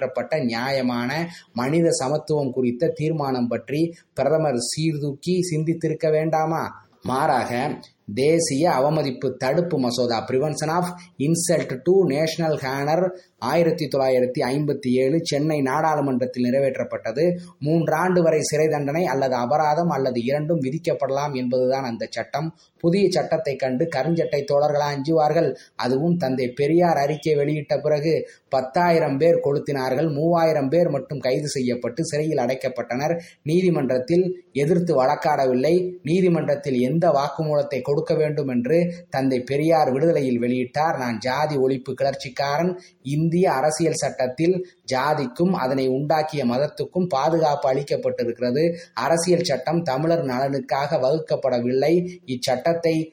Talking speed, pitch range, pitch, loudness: 105 wpm, 130-165 Hz, 150 Hz, -22 LUFS